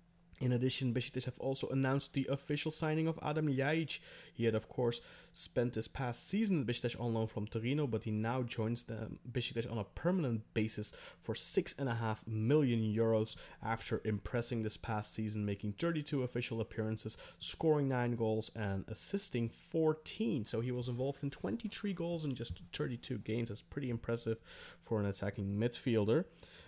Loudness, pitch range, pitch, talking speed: -37 LUFS, 110-140 Hz, 120 Hz, 165 wpm